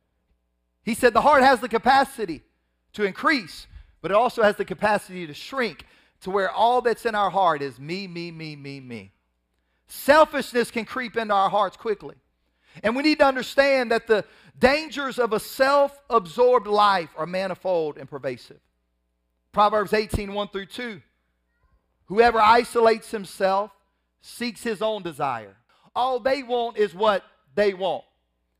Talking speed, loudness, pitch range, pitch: 150 wpm, -22 LUFS, 160-240 Hz, 210 Hz